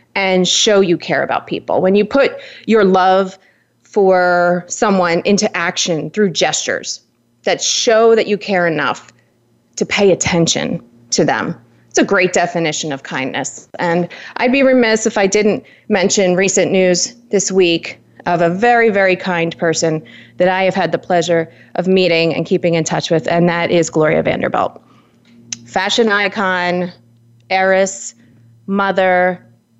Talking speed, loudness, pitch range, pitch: 150 wpm, -14 LUFS, 165-195 Hz, 180 Hz